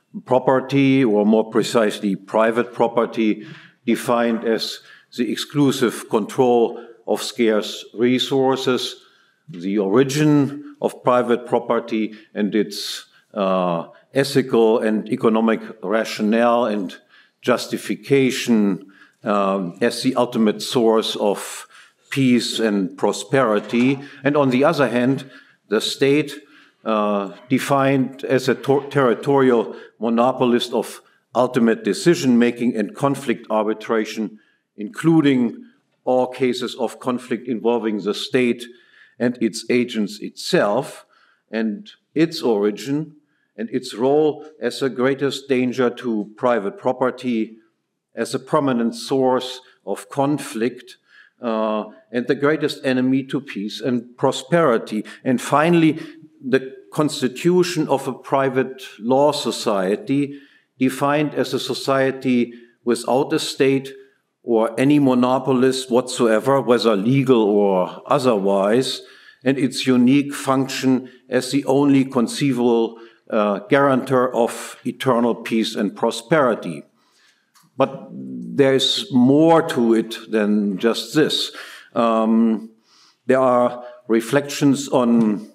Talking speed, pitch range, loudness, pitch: 105 wpm, 115-135 Hz, -19 LUFS, 125 Hz